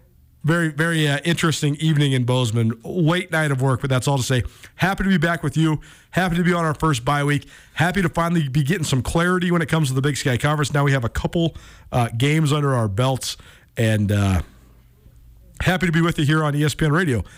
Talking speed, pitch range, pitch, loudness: 230 wpm, 125-165 Hz, 145 Hz, -20 LUFS